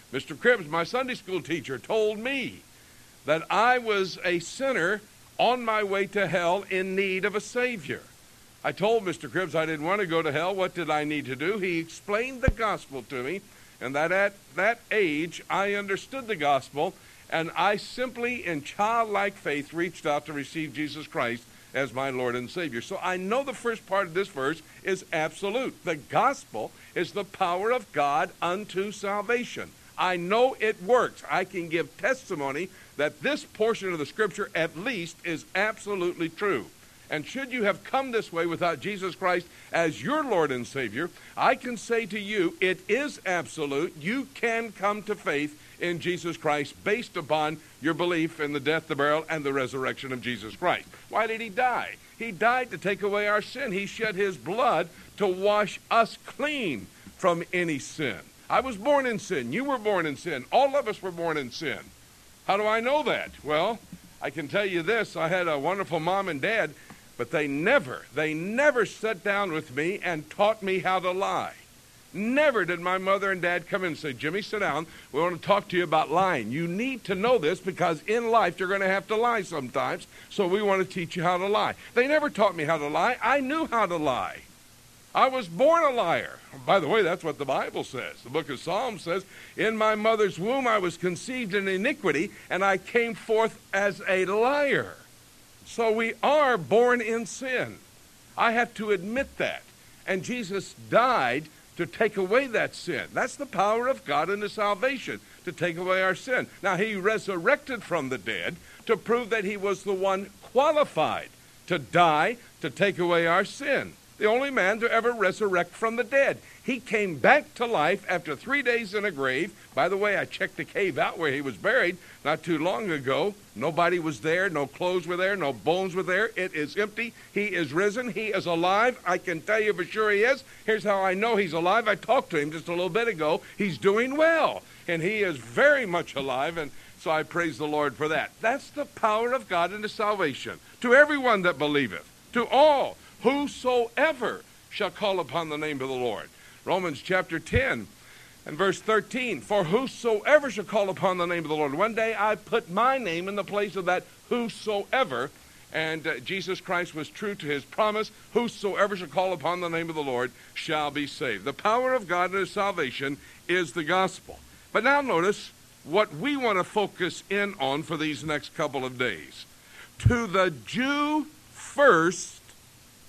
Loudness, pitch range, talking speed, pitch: -27 LUFS, 165-225 Hz, 200 wpm, 195 Hz